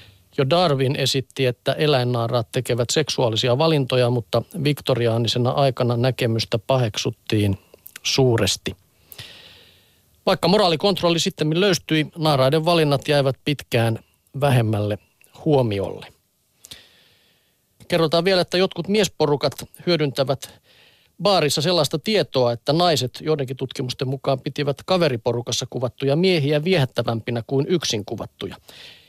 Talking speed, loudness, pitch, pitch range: 95 wpm, -21 LUFS, 135 Hz, 120-155 Hz